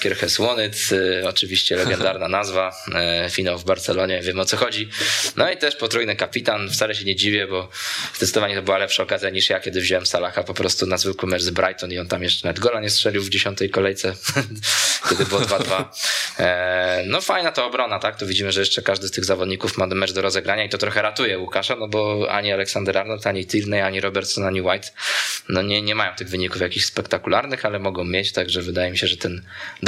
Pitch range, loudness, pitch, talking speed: 90-105 Hz, -20 LUFS, 95 Hz, 210 wpm